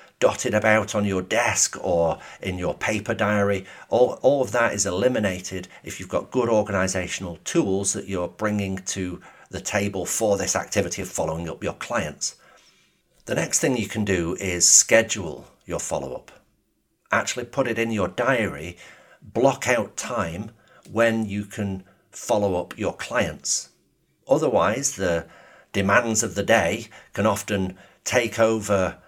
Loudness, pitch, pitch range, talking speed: -23 LUFS, 100 Hz, 95-110 Hz, 150 wpm